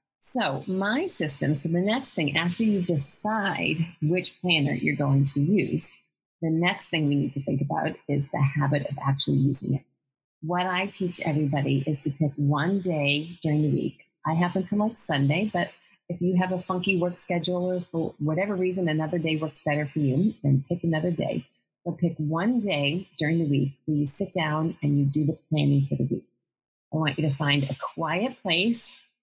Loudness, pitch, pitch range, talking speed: -26 LUFS, 160 Hz, 145-180 Hz, 200 wpm